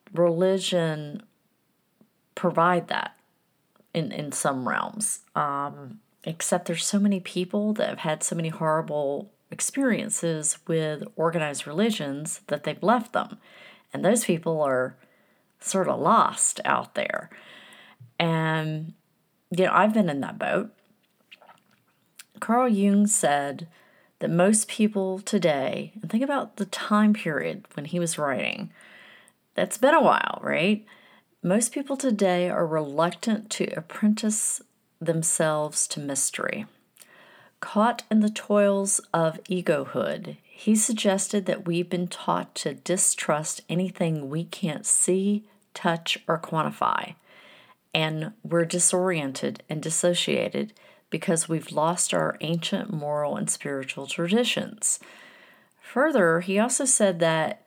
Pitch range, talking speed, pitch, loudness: 160-210 Hz, 120 wpm, 180 Hz, -25 LUFS